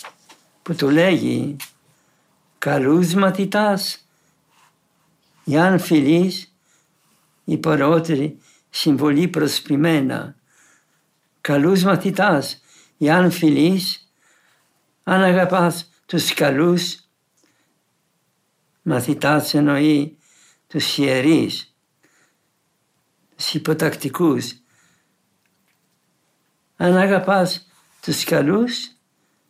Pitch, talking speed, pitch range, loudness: 165 Hz, 60 wpm, 150-185 Hz, -18 LUFS